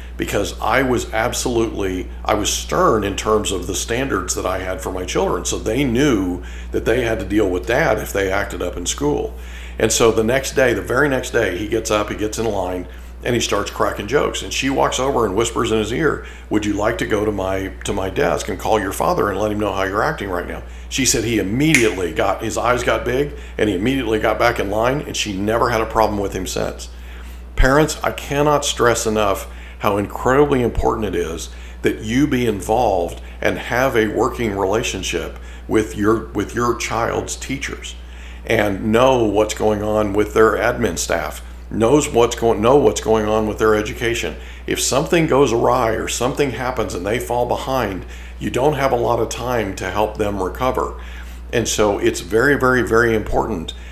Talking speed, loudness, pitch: 205 wpm, -19 LUFS, 105 Hz